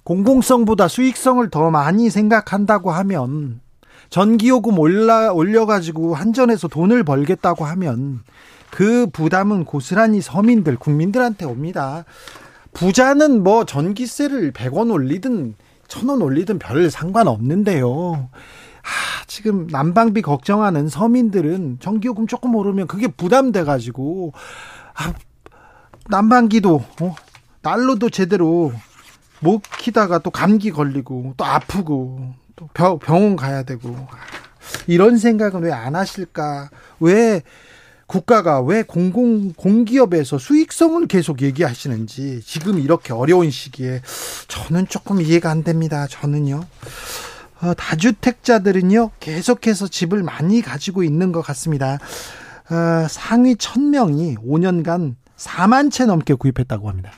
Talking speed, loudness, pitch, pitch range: 260 characters per minute, -17 LUFS, 180 Hz, 145-225 Hz